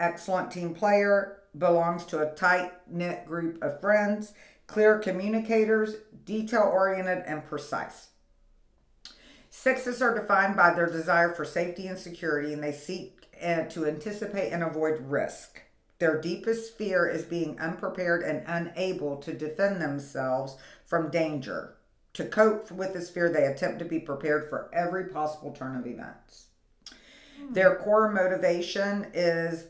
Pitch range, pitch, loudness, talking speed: 160-200 Hz, 175 Hz, -28 LUFS, 135 wpm